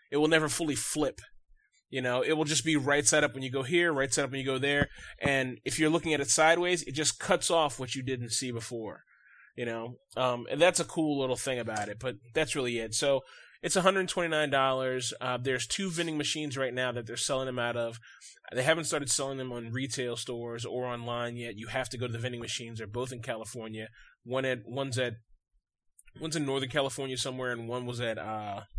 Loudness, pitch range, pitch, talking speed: -30 LUFS, 120-150 Hz, 130 Hz, 225 wpm